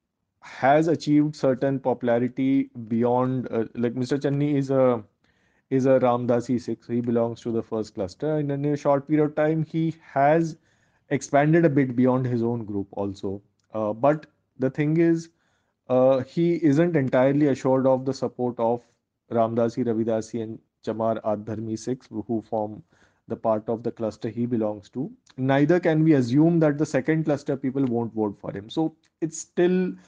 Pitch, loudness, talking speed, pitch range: 130 Hz, -24 LUFS, 170 wpm, 115-145 Hz